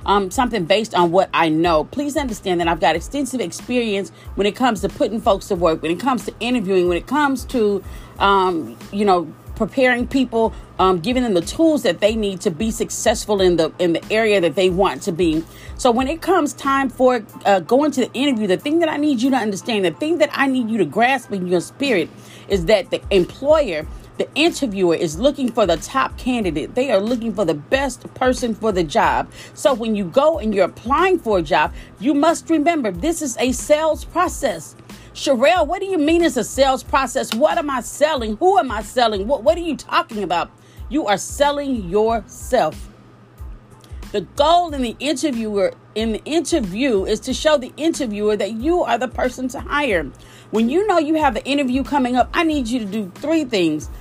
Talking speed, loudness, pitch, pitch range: 210 wpm, -19 LUFS, 245 Hz, 200-285 Hz